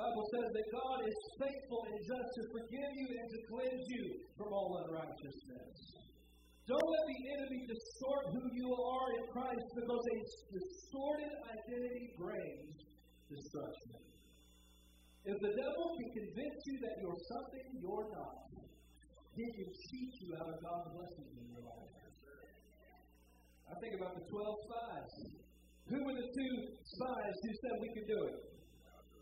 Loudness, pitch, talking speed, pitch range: -44 LUFS, 230 Hz, 150 wpm, 175-255 Hz